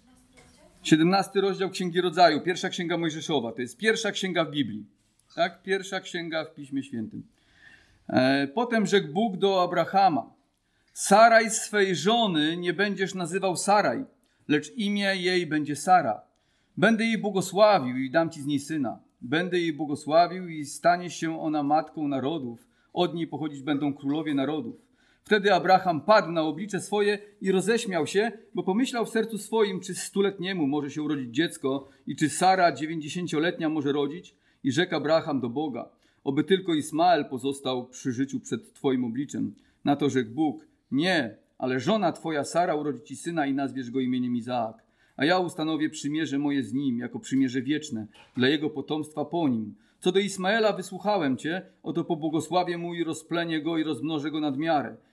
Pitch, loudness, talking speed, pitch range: 165 Hz, -26 LUFS, 160 wpm, 145-195 Hz